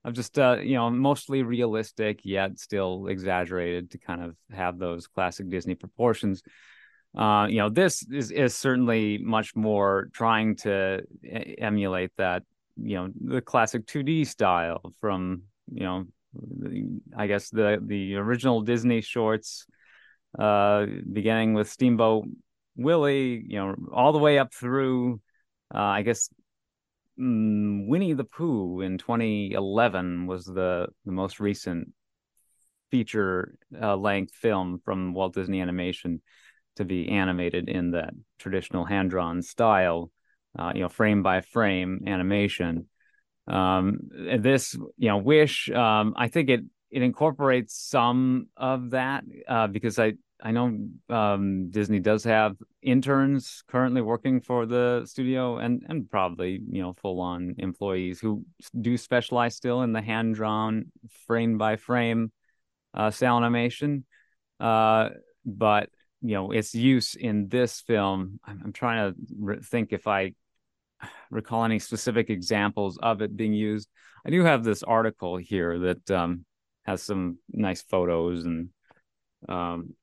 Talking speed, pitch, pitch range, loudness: 140 wpm, 105 Hz, 95-120 Hz, -26 LUFS